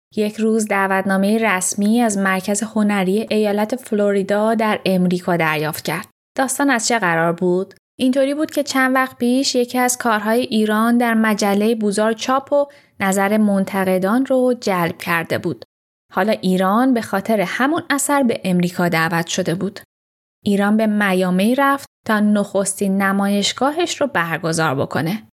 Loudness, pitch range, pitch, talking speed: -18 LUFS, 190-240 Hz, 210 Hz, 140 wpm